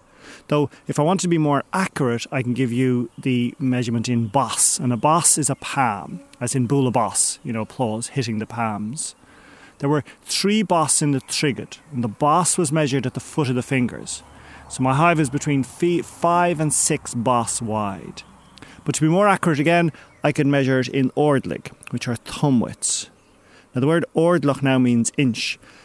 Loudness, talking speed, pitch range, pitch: -20 LUFS, 195 wpm, 120-155 Hz, 135 Hz